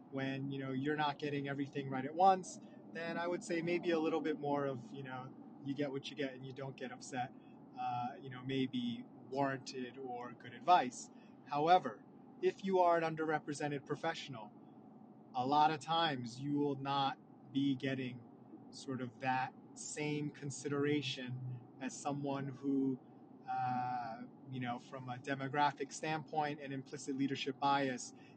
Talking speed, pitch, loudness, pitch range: 160 wpm, 140 Hz, -38 LUFS, 135-160 Hz